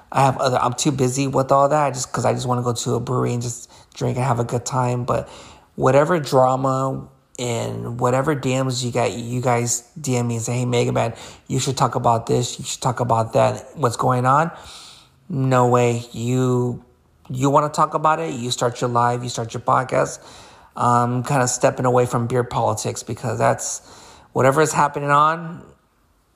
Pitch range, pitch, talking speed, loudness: 120-135 Hz, 125 Hz, 200 wpm, -20 LUFS